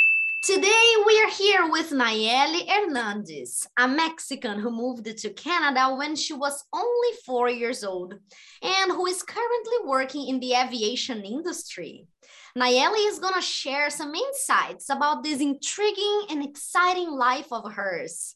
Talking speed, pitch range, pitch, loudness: 145 wpm, 250-375 Hz, 290 Hz, -24 LUFS